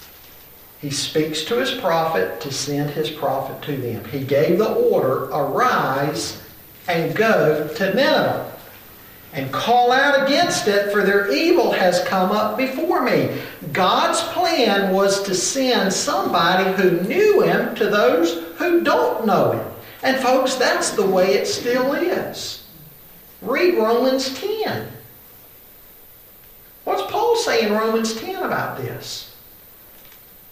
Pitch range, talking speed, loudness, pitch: 165-275 Hz, 130 wpm, -19 LUFS, 205 Hz